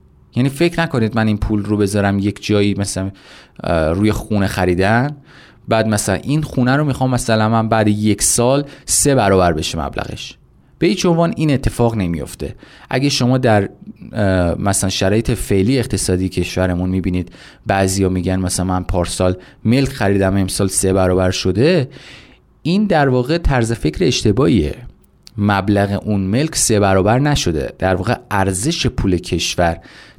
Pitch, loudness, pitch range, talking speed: 105 Hz, -16 LUFS, 95-125 Hz, 145 wpm